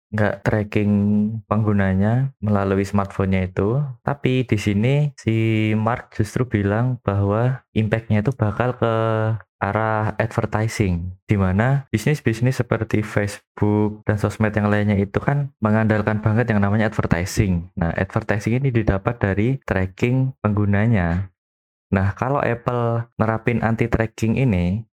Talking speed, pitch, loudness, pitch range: 120 wpm, 110 Hz, -21 LUFS, 100-115 Hz